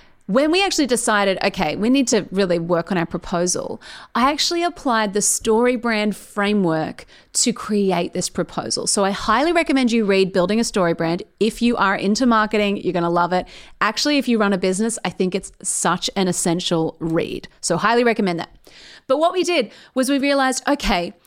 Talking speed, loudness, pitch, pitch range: 190 wpm, -19 LUFS, 205 Hz, 180-245 Hz